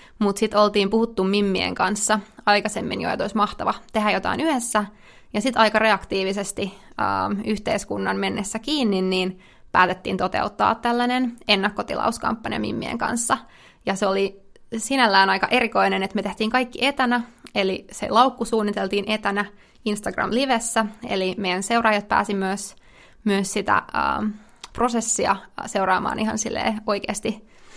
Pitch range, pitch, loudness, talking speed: 200-230 Hz, 215 Hz, -22 LUFS, 125 wpm